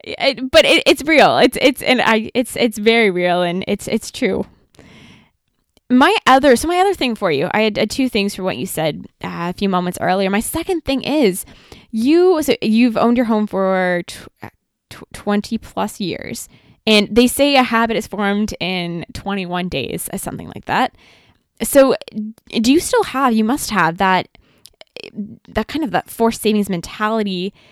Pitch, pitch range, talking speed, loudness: 220 Hz, 195-260 Hz, 185 wpm, -16 LUFS